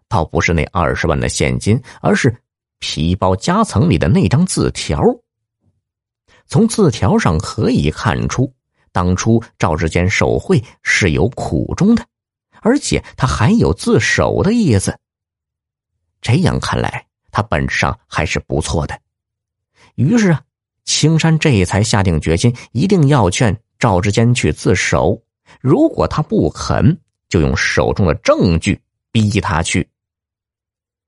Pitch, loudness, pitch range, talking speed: 105 Hz, -15 LUFS, 90-125 Hz, 195 characters per minute